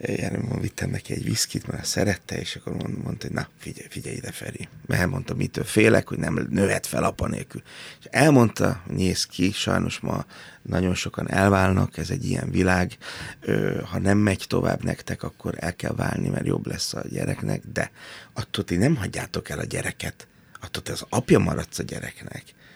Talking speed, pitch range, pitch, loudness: 180 wpm, 90-125 Hz, 100 Hz, -25 LUFS